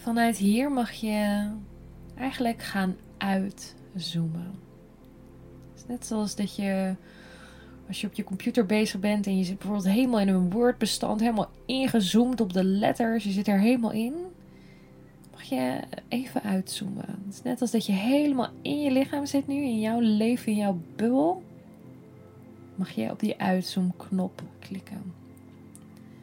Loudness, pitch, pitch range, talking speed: -27 LUFS, 210 Hz, 190-235 Hz, 145 wpm